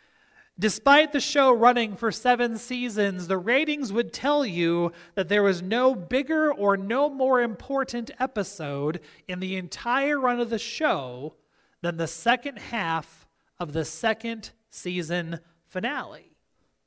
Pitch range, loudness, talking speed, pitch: 175-255 Hz, -25 LUFS, 135 wpm, 225 Hz